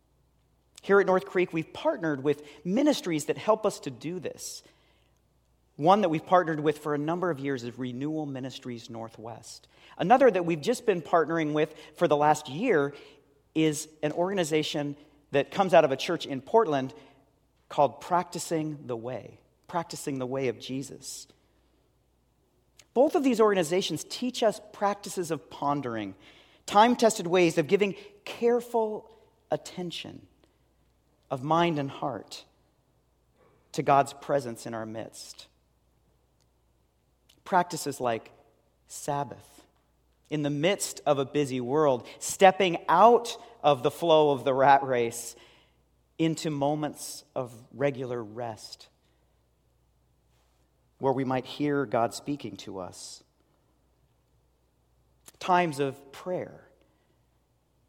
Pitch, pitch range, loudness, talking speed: 150 Hz, 130-180 Hz, -27 LUFS, 125 wpm